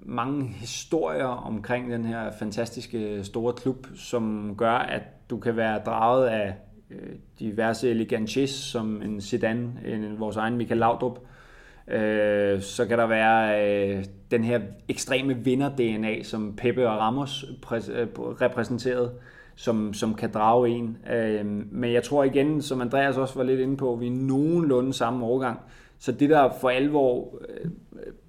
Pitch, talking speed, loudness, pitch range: 120 Hz, 140 wpm, -26 LUFS, 110-130 Hz